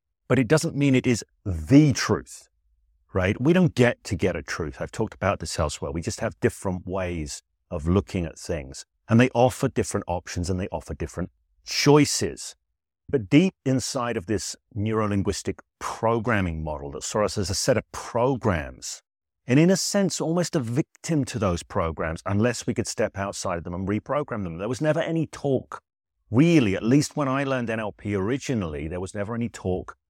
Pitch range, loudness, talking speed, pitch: 90-135 Hz, -25 LUFS, 190 wpm, 110 Hz